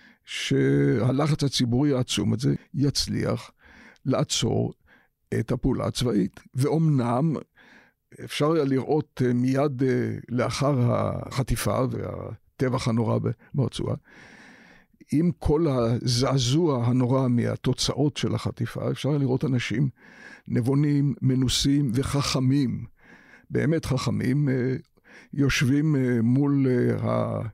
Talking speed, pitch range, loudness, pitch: 85 wpm, 120-140 Hz, -25 LUFS, 130 Hz